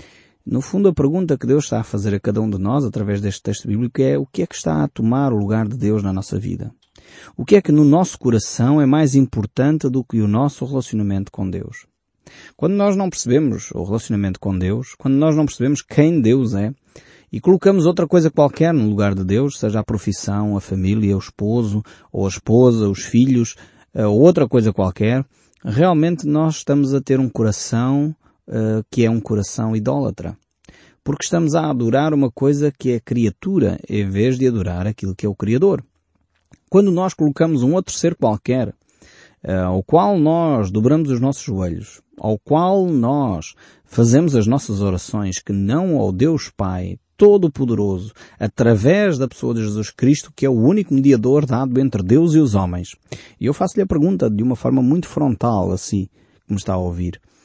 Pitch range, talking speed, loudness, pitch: 105-145 Hz, 190 wpm, -18 LUFS, 120 Hz